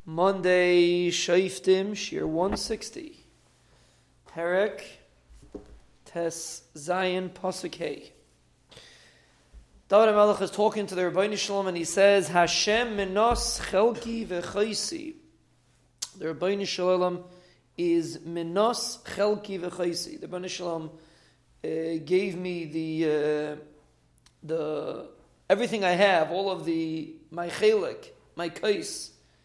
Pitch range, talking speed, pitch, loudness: 165-200 Hz, 100 wpm, 180 Hz, -27 LUFS